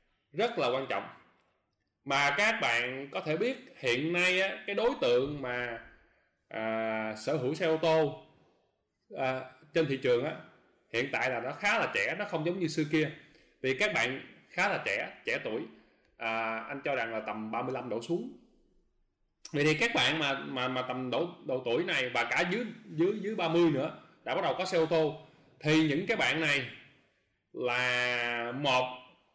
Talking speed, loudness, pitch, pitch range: 185 wpm, -31 LUFS, 140 Hz, 125-165 Hz